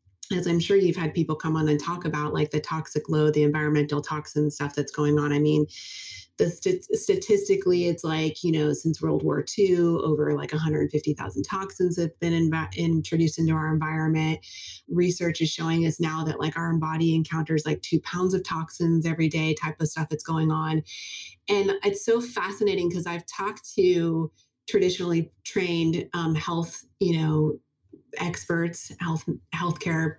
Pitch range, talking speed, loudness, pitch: 155-175 Hz, 170 wpm, -26 LUFS, 160 Hz